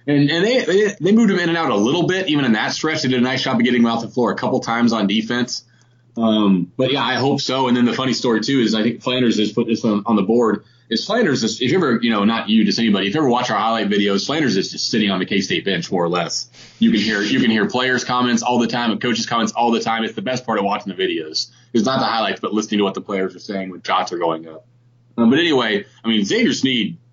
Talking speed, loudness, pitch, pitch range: 300 wpm, -18 LUFS, 120 Hz, 110-130 Hz